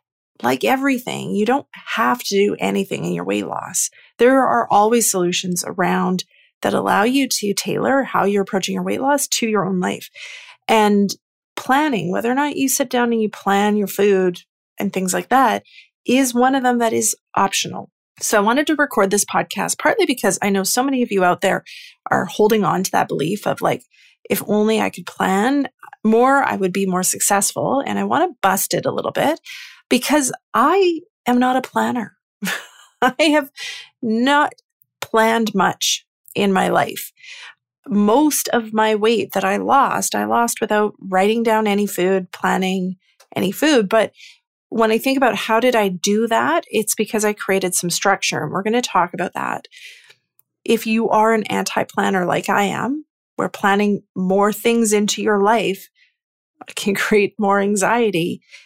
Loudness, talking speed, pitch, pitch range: -18 LUFS, 180 wpm, 220 Hz, 195-265 Hz